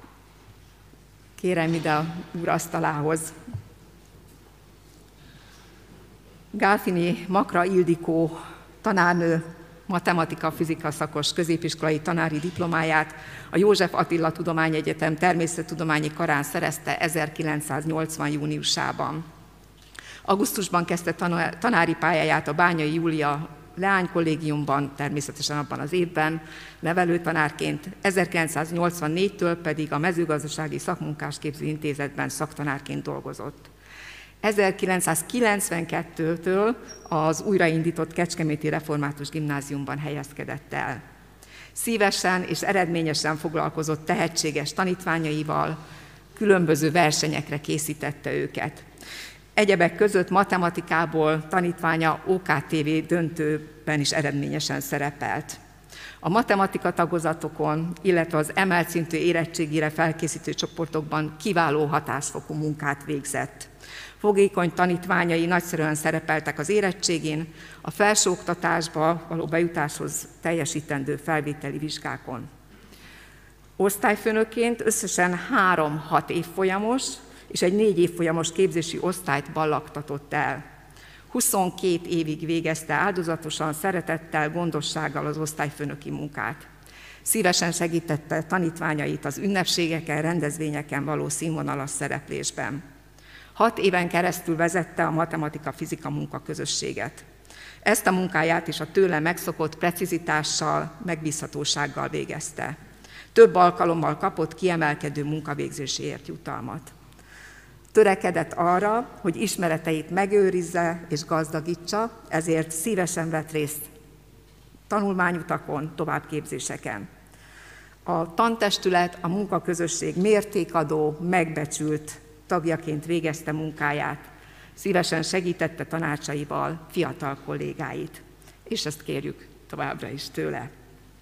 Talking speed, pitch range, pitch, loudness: 85 wpm, 150-175 Hz, 160 Hz, -25 LUFS